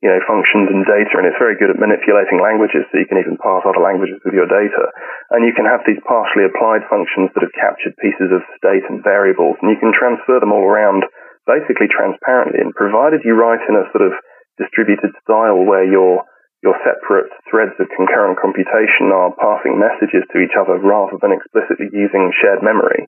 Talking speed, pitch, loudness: 200 wpm, 115 Hz, -13 LUFS